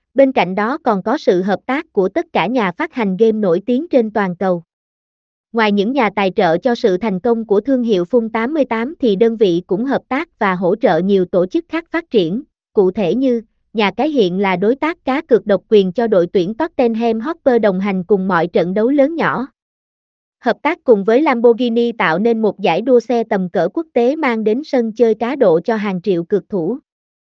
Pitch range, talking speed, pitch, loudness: 200-255 Hz, 225 wpm, 230 Hz, -16 LUFS